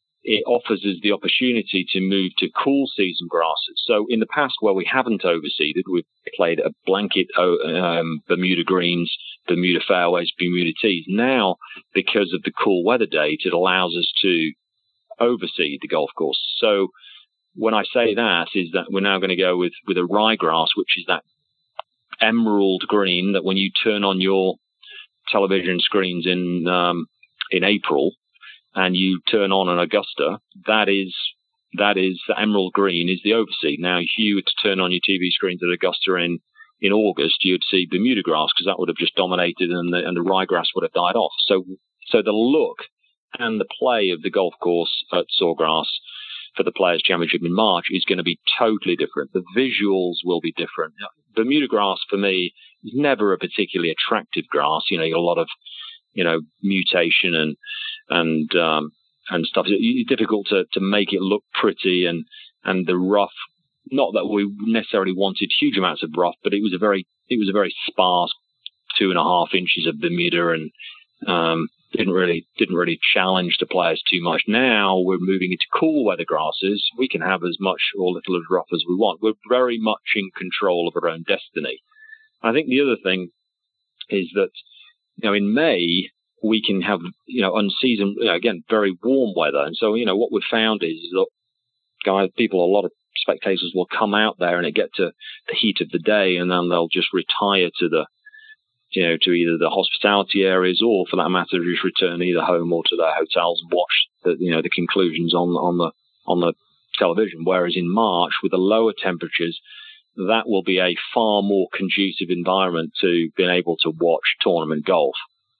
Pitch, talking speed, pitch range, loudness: 95 Hz, 195 wpm, 90-110 Hz, -20 LUFS